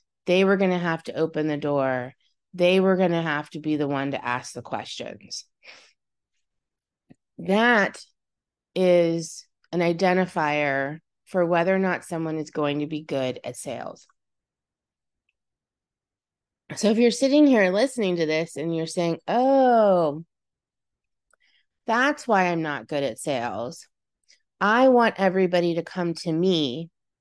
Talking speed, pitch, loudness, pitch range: 140 wpm, 170 Hz, -23 LUFS, 150-190 Hz